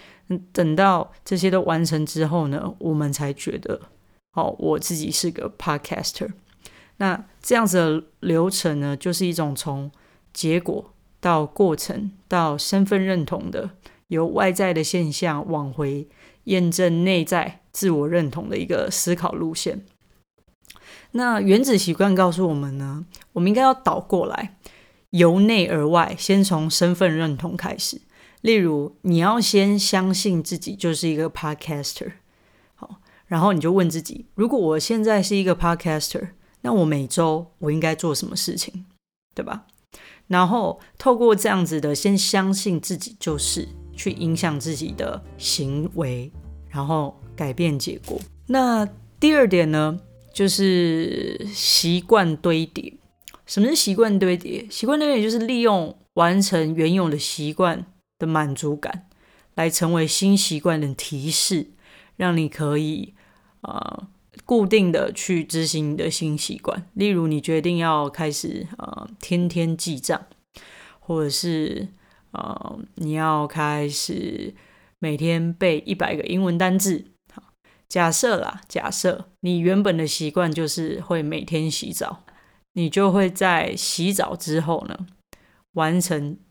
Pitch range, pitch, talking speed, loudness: 155-195 Hz, 175 Hz, 225 characters per minute, -22 LUFS